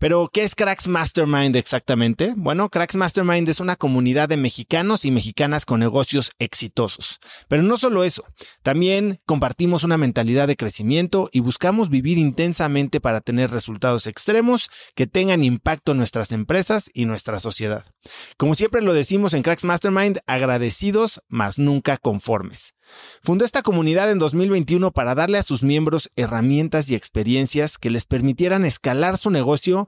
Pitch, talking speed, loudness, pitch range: 150 Hz, 155 wpm, -20 LUFS, 125-185 Hz